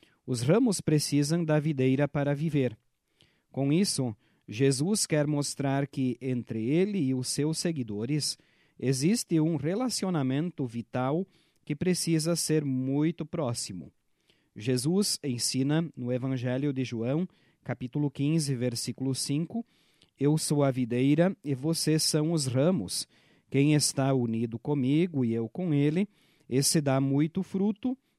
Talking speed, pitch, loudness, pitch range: 125 wpm, 145 Hz, -28 LUFS, 130-165 Hz